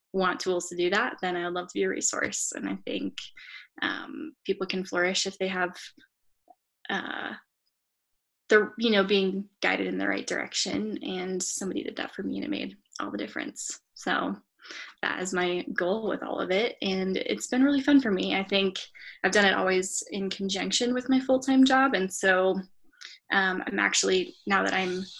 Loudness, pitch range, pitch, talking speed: -27 LUFS, 185-230 Hz, 190 Hz, 195 wpm